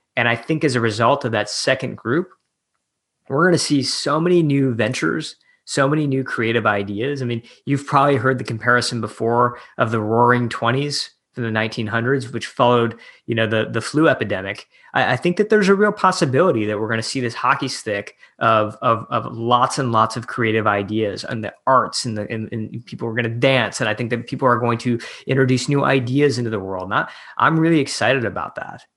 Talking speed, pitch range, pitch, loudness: 215 wpm, 115-140 Hz, 120 Hz, -19 LUFS